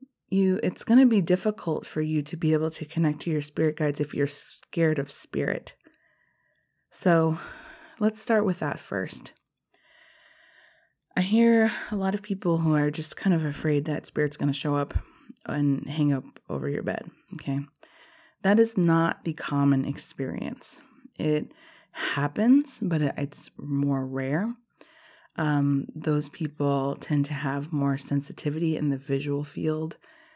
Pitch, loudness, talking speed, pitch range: 160 Hz, -27 LUFS, 150 wpm, 145-220 Hz